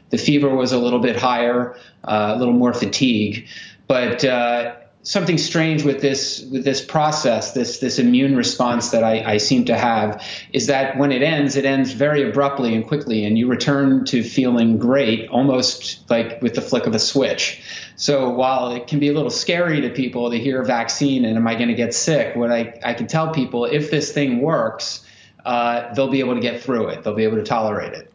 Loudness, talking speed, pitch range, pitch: -19 LUFS, 215 wpm, 120-140 Hz, 125 Hz